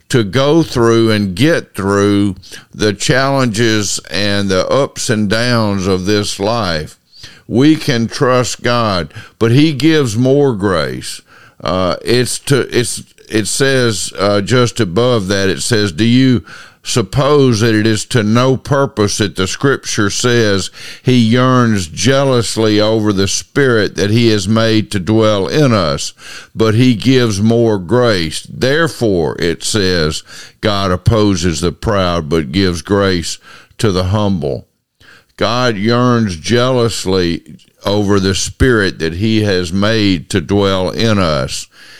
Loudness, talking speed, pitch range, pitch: -13 LUFS, 135 wpm, 95-120 Hz, 110 Hz